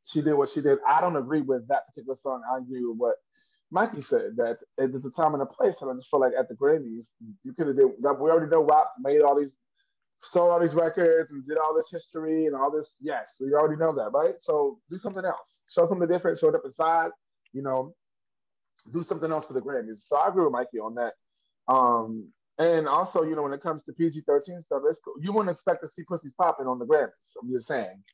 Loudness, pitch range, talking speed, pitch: -26 LUFS, 135-195 Hz, 245 wpm, 160 Hz